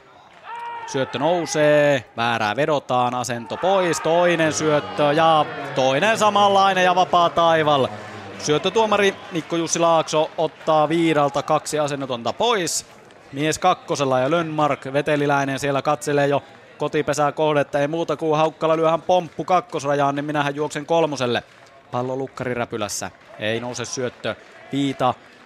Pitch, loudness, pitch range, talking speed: 150 Hz, -20 LUFS, 135-165 Hz, 125 wpm